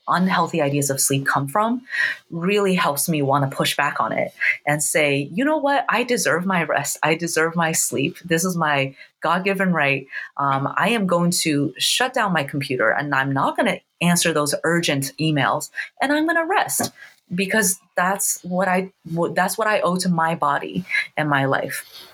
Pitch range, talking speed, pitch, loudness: 145-190 Hz, 185 wpm, 165 Hz, -20 LUFS